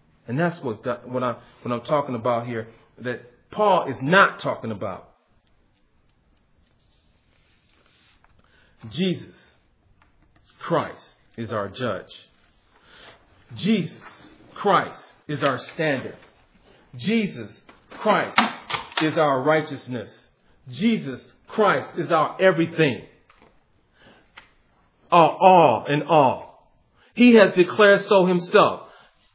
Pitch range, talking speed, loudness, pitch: 120-180 Hz, 95 wpm, -21 LUFS, 150 Hz